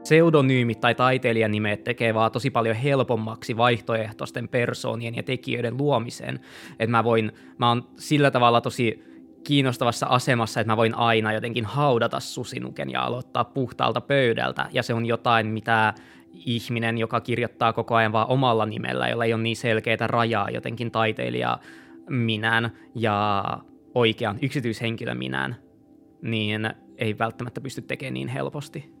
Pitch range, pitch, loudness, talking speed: 110-120 Hz, 115 Hz, -24 LUFS, 140 wpm